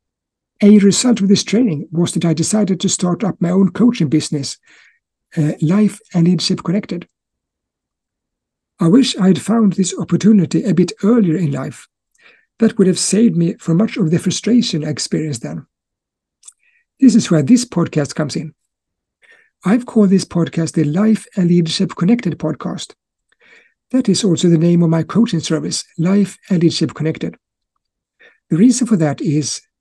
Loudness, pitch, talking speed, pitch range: -15 LUFS, 185 Hz, 165 wpm, 165-215 Hz